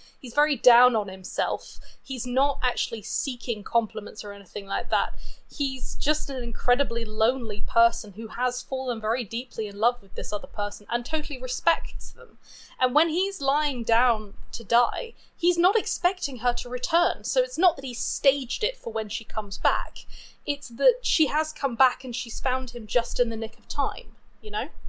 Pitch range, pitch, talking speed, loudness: 230-285 Hz, 250 Hz, 190 wpm, -26 LUFS